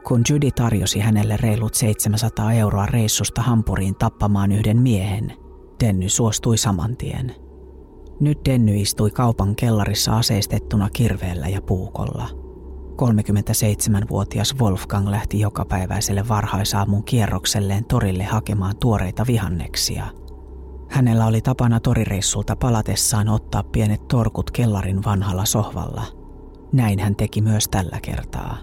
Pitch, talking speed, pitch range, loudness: 105 Hz, 110 wpm, 100-115 Hz, -20 LUFS